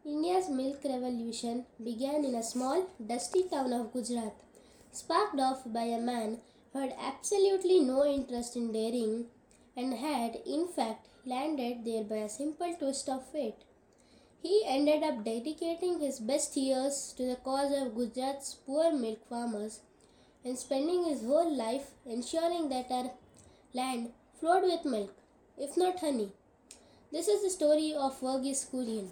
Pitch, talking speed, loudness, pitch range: 265 Hz, 150 wpm, -33 LUFS, 240-300 Hz